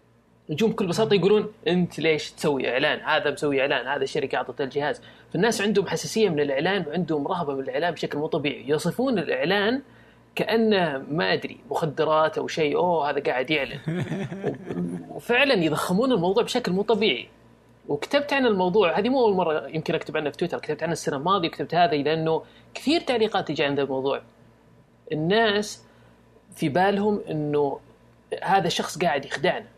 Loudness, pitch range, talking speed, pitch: -24 LUFS, 155-210 Hz, 155 wpm, 175 Hz